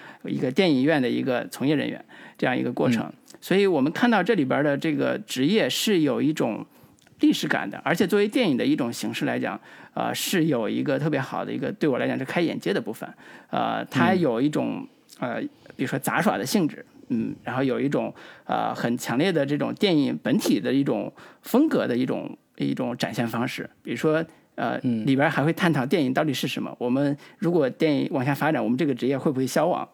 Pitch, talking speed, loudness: 160 Hz, 315 characters per minute, -24 LUFS